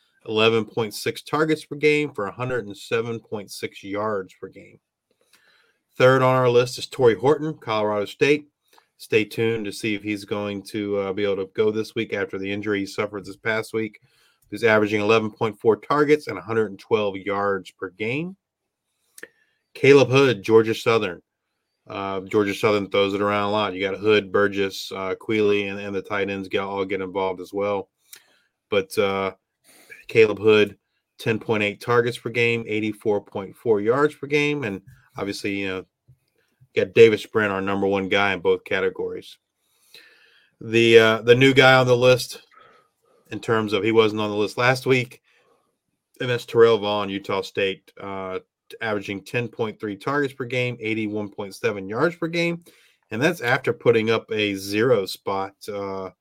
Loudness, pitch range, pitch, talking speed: -22 LUFS, 100-125 Hz, 110 Hz, 160 wpm